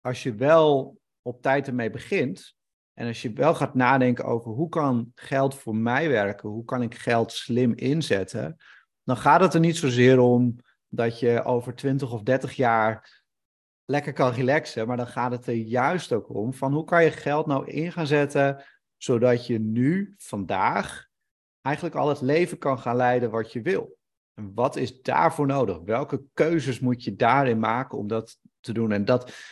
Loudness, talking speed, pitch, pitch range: -24 LUFS, 185 wpm, 125 Hz, 115-140 Hz